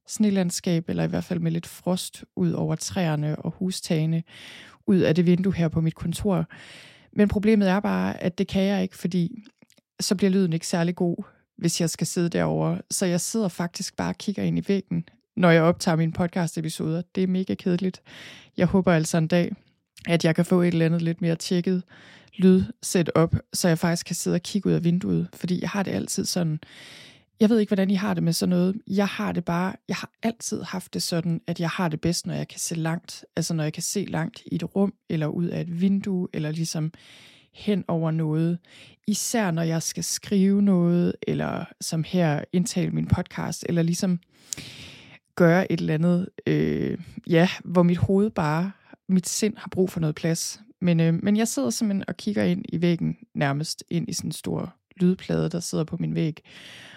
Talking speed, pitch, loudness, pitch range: 210 wpm, 175 Hz, -25 LUFS, 165-195 Hz